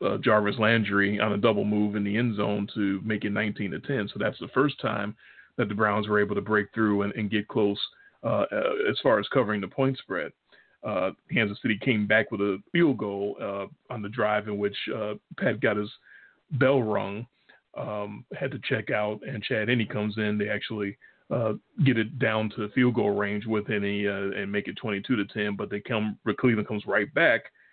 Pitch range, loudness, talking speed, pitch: 100-110 Hz, -27 LUFS, 220 wpm, 105 Hz